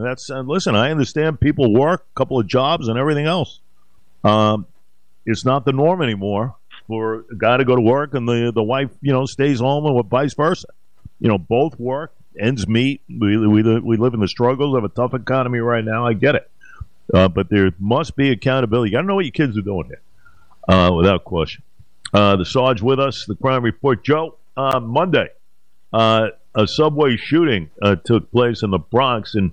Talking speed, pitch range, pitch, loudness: 205 wpm, 105-135 Hz, 120 Hz, -18 LUFS